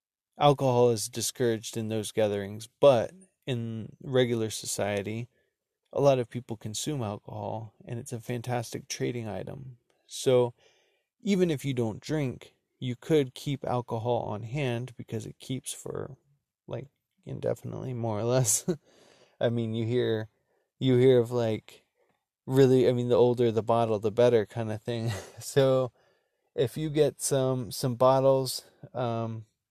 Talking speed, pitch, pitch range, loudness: 145 wpm, 120 Hz, 115-130 Hz, -28 LUFS